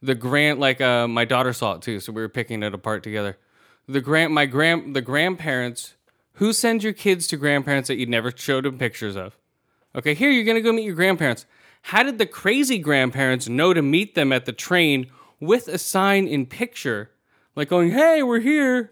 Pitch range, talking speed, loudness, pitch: 125-190 Hz, 205 wpm, -21 LUFS, 145 Hz